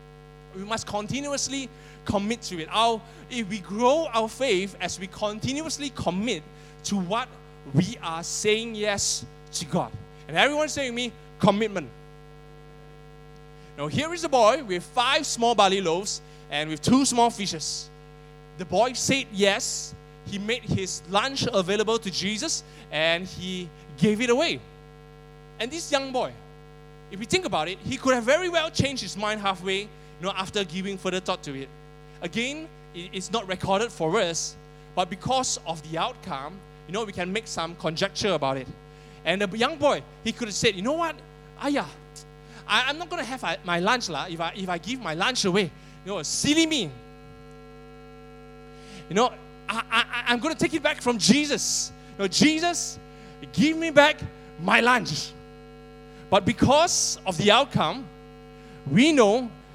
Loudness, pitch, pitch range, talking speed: -25 LUFS, 185 Hz, 150-230 Hz, 165 wpm